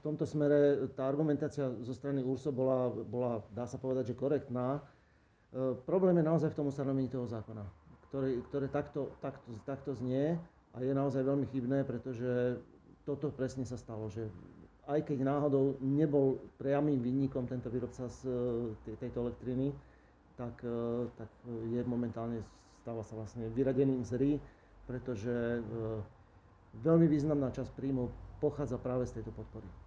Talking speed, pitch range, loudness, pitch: 145 wpm, 115-140 Hz, -35 LUFS, 125 Hz